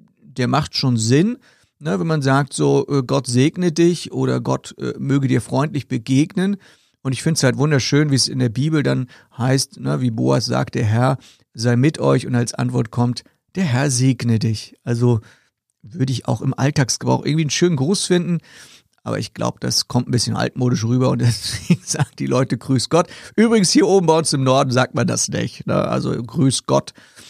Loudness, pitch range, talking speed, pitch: -18 LUFS, 120-155 Hz, 200 wpm, 130 Hz